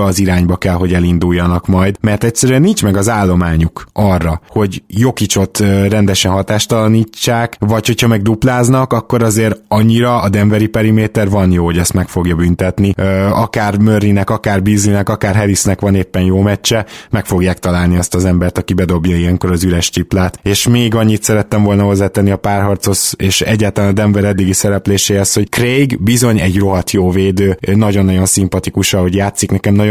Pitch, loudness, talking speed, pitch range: 100 Hz, -12 LUFS, 165 wpm, 95-110 Hz